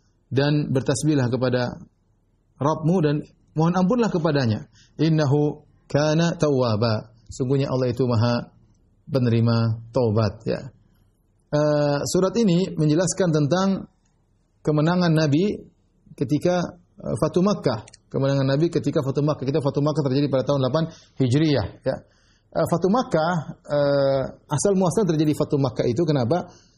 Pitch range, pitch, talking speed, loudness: 125-160 Hz, 145 Hz, 120 wpm, -22 LUFS